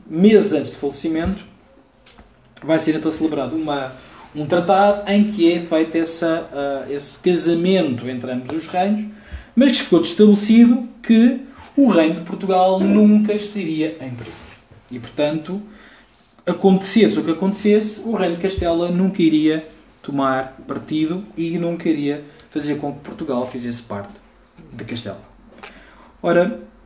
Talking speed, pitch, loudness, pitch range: 135 wpm, 170 Hz, -18 LUFS, 145-200 Hz